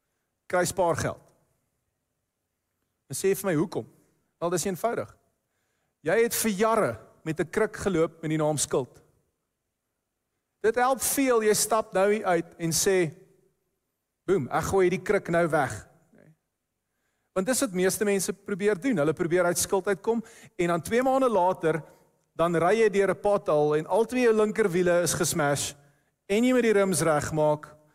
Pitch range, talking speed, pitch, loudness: 160-210 Hz, 155 wpm, 185 Hz, -26 LUFS